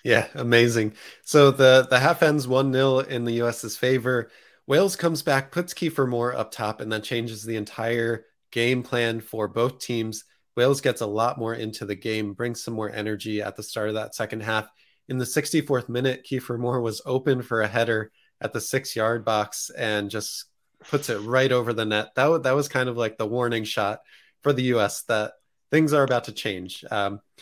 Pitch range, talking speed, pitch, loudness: 110-130 Hz, 210 wpm, 120 Hz, -24 LUFS